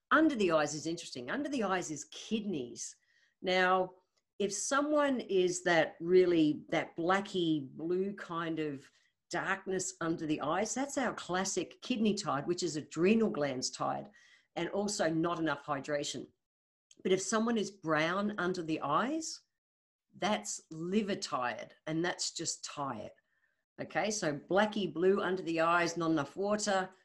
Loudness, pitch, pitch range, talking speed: -33 LUFS, 180 Hz, 160-200 Hz, 145 wpm